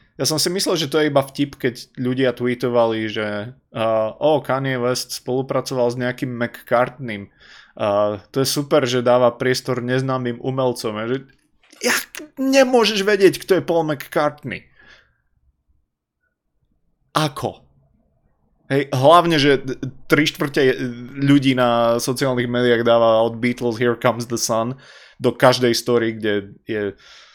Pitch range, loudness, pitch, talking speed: 120-140 Hz, -19 LUFS, 125 Hz, 130 wpm